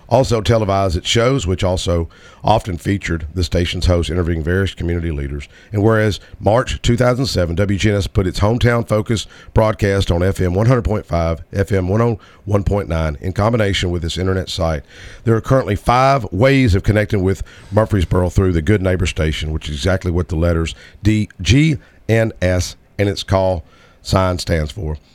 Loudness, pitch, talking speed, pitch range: -17 LUFS, 95 Hz, 155 wpm, 85-105 Hz